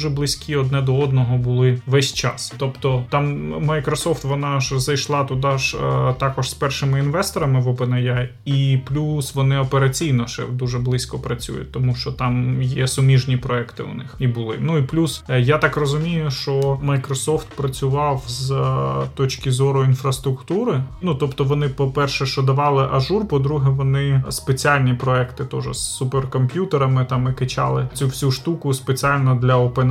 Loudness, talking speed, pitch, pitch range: -20 LUFS, 160 wpm, 135 Hz, 130-145 Hz